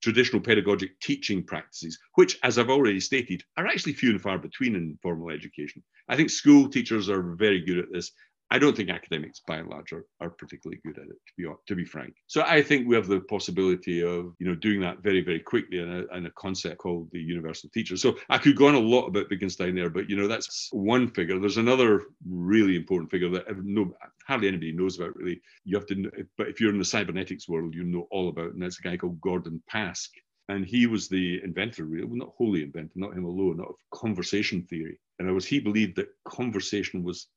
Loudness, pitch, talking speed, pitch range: -26 LUFS, 95 Hz, 230 wpm, 90-110 Hz